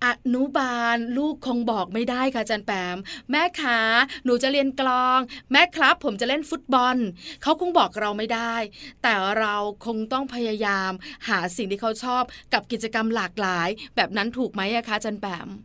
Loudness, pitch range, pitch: -23 LUFS, 210-260 Hz, 235 Hz